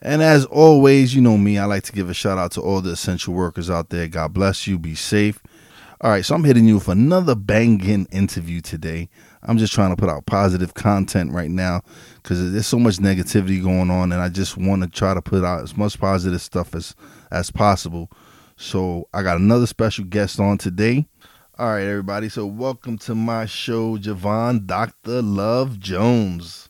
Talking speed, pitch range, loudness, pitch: 200 wpm, 90-115 Hz, -19 LUFS, 100 Hz